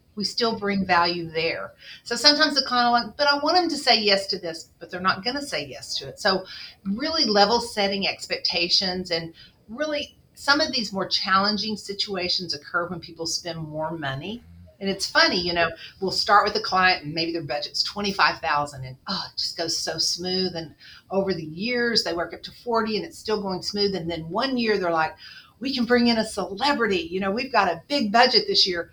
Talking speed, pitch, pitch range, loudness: 215 wpm, 195 Hz, 170-230 Hz, -23 LUFS